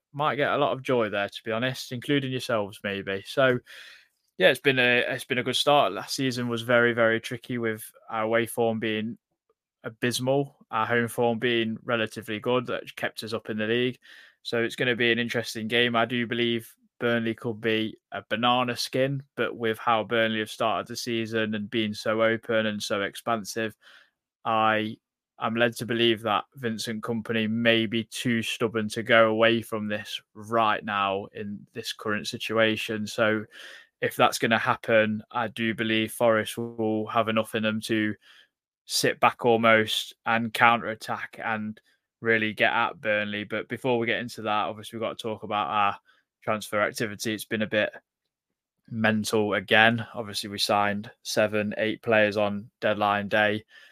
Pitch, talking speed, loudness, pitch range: 115 Hz, 175 wpm, -26 LUFS, 110-120 Hz